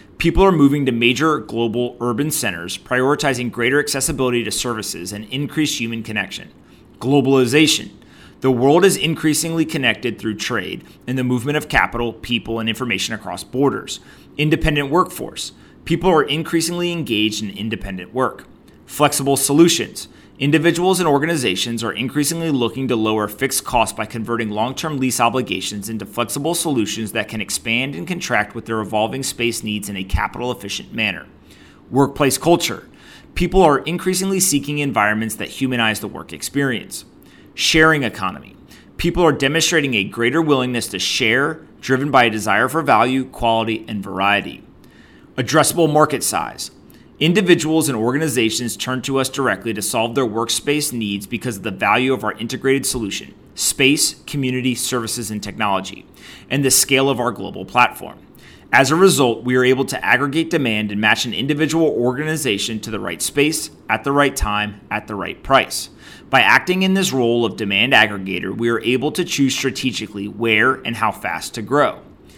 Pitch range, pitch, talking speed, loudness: 110-145 Hz, 125 Hz, 160 wpm, -18 LUFS